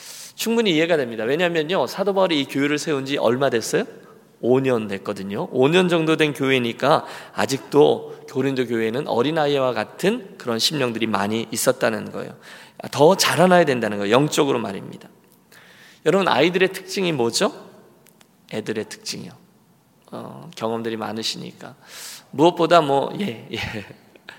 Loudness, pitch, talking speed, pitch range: -20 LUFS, 140 Hz, 320 characters per minute, 115-170 Hz